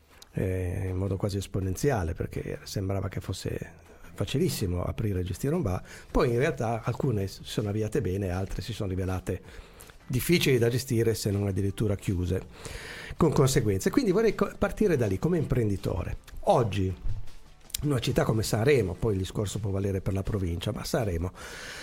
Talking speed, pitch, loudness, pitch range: 165 wpm, 105 Hz, -29 LUFS, 95-120 Hz